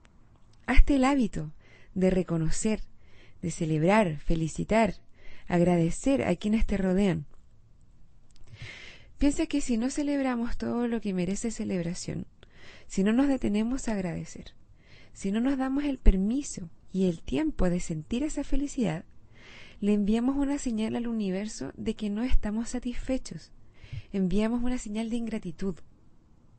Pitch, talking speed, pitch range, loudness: 205 Hz, 130 wpm, 170-240 Hz, -29 LUFS